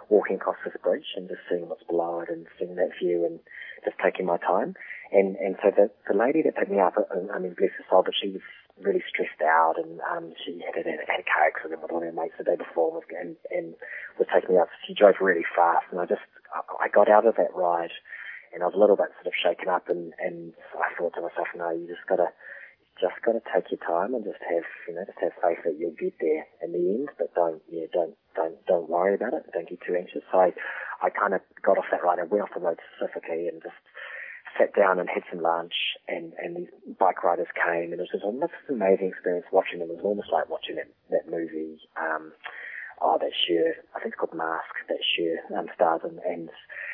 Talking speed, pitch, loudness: 250 wpm, 90 Hz, -26 LUFS